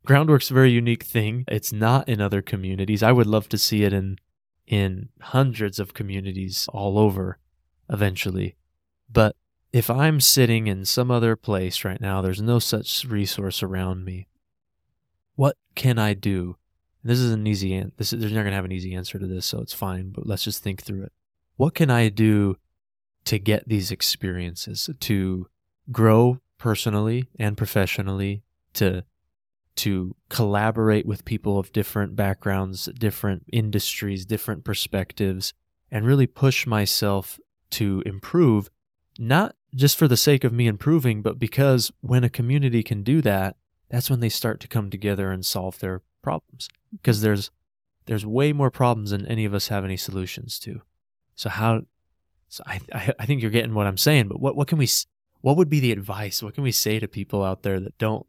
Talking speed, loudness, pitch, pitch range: 175 wpm, -23 LUFS, 105 Hz, 95-120 Hz